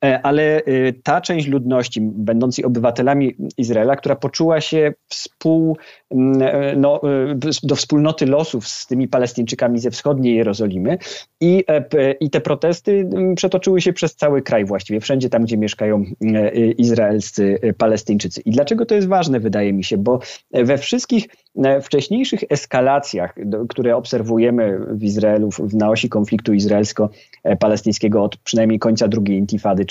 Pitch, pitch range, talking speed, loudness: 125 Hz, 110-150 Hz, 130 wpm, -17 LUFS